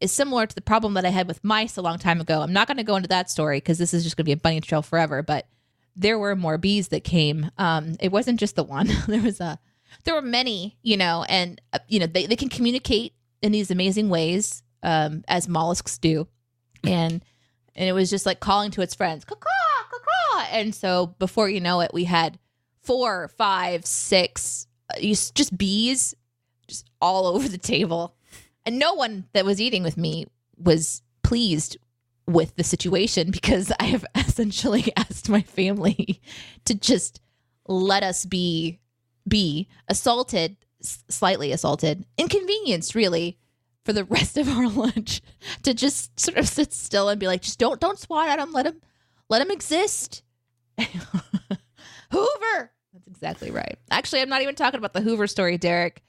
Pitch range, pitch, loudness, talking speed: 160-220 Hz, 185 Hz, -23 LUFS, 180 wpm